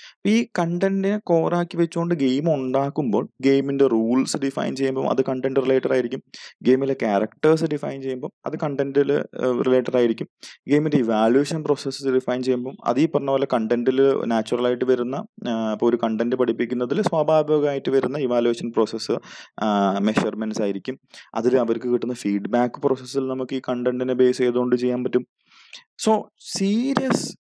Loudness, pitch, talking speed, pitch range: -22 LUFS, 130 Hz, 125 wpm, 125-145 Hz